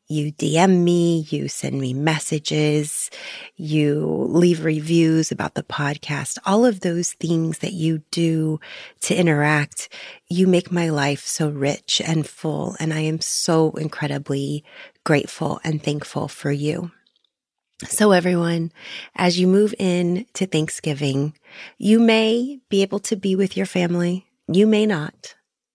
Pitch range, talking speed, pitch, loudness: 150-185 Hz, 140 wpm, 165 Hz, -20 LUFS